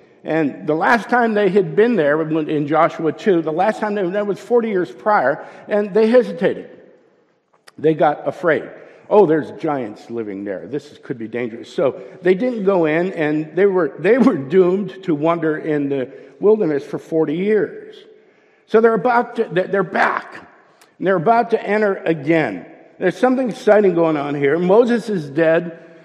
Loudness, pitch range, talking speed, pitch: -18 LUFS, 155-220 Hz, 175 wpm, 185 Hz